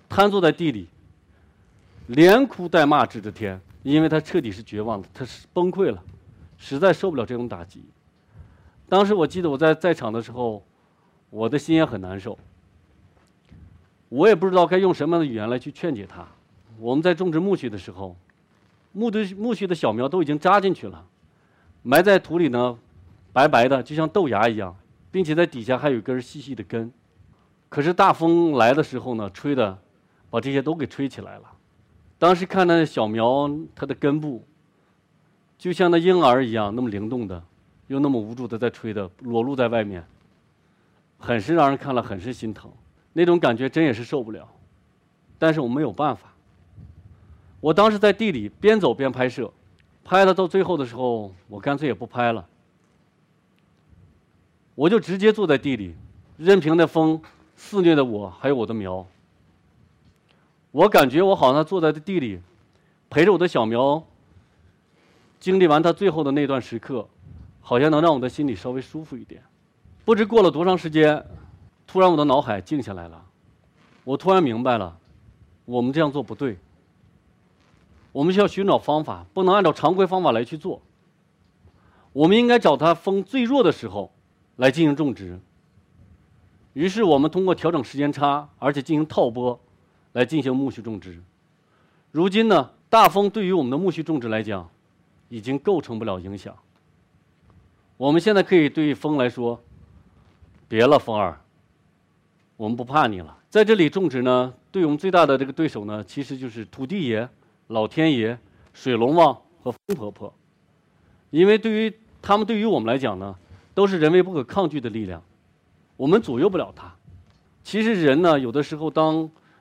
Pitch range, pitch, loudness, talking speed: 100-160 Hz, 125 Hz, -21 LUFS, 255 characters per minute